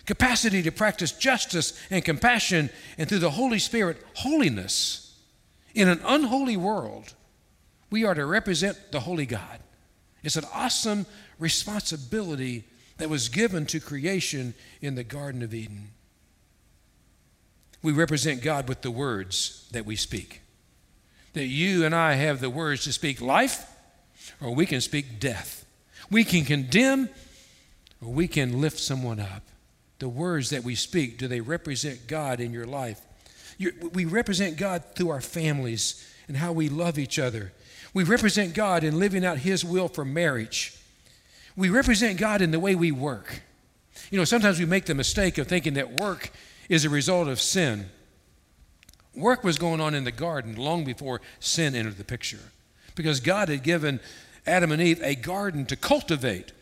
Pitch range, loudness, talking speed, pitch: 125-185 Hz, -26 LUFS, 160 wpm, 155 Hz